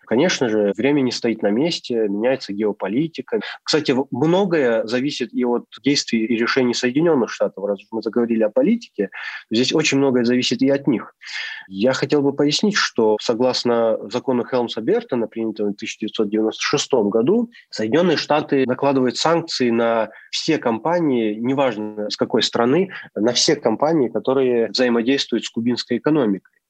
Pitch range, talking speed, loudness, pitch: 110-140 Hz, 140 wpm, -19 LUFS, 125 Hz